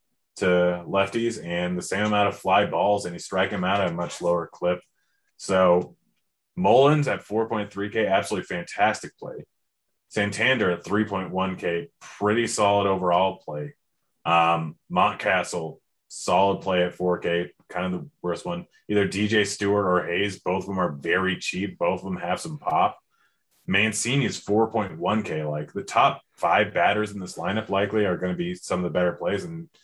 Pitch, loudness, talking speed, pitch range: 95 Hz, -24 LUFS, 165 wpm, 90-105 Hz